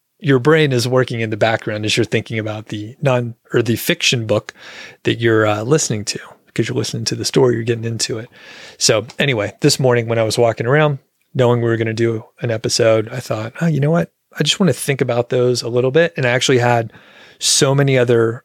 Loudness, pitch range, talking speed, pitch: -16 LUFS, 115-135 Hz, 235 wpm, 120 Hz